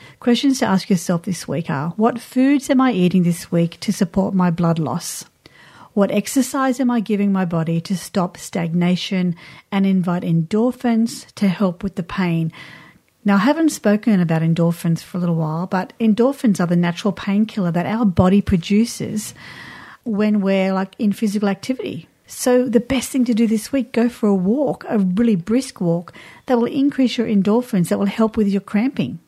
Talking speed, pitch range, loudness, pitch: 185 wpm, 180-235 Hz, -19 LUFS, 200 Hz